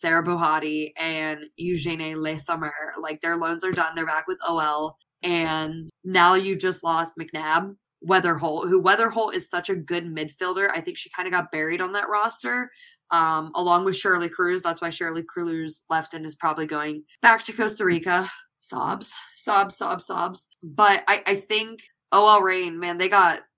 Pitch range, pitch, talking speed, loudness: 160-190 Hz, 175 Hz, 175 wpm, -23 LUFS